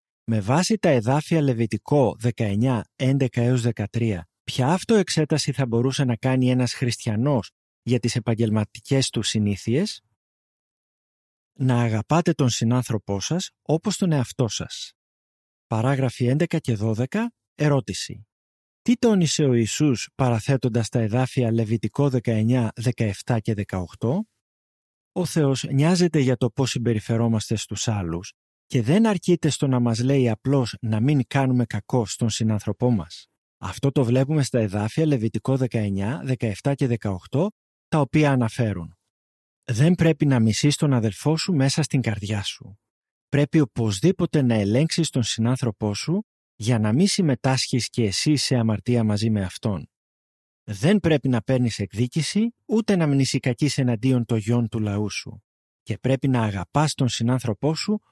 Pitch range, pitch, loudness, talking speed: 110-145 Hz, 125 Hz, -23 LUFS, 135 wpm